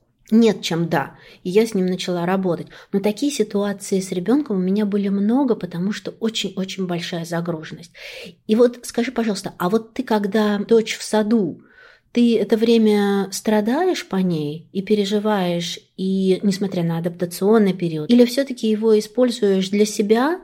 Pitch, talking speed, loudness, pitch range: 205 Hz, 155 wpm, -20 LUFS, 185-225 Hz